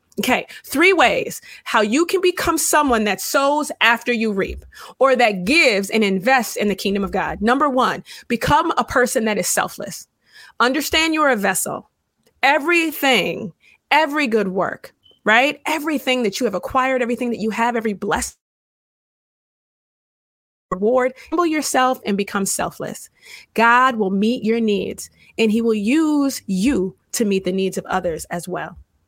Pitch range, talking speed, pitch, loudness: 205-285 Hz, 155 wpm, 240 Hz, -18 LUFS